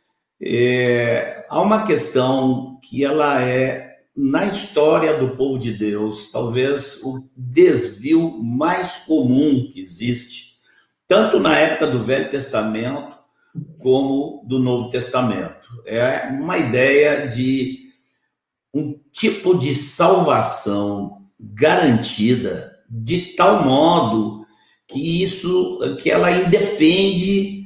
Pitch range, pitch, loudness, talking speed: 125-160 Hz, 135 Hz, -18 LUFS, 100 wpm